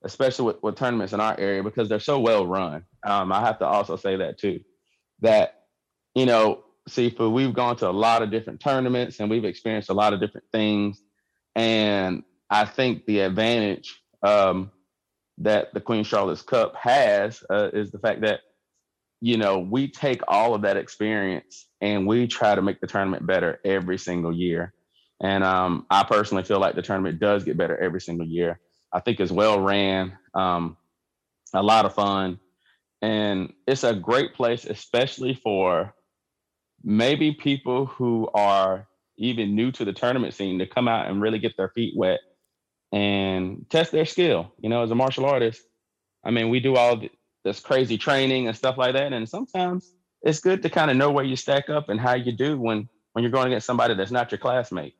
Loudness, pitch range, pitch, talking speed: -23 LUFS, 95-125 Hz, 110 Hz, 190 wpm